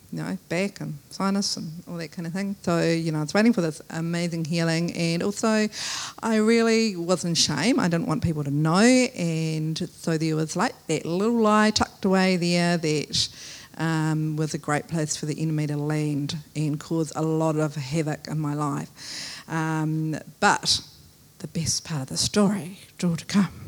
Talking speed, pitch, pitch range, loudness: 195 wpm, 165 Hz, 155-185 Hz, -24 LUFS